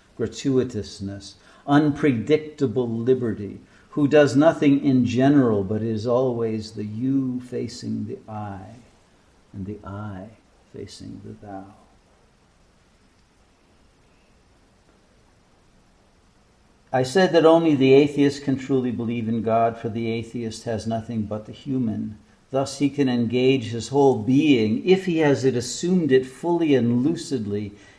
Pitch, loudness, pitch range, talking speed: 120 Hz, -21 LUFS, 110-140 Hz, 120 wpm